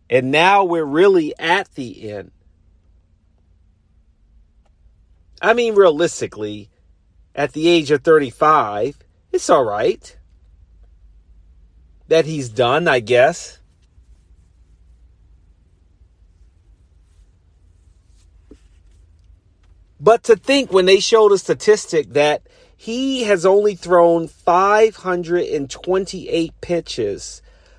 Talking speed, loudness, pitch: 80 wpm, -16 LUFS, 95 Hz